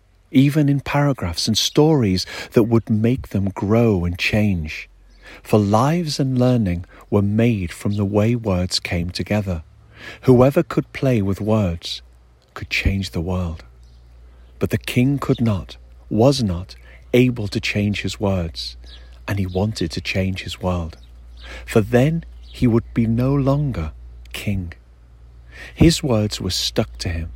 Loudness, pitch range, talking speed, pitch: -20 LUFS, 80-115 Hz, 145 wpm, 100 Hz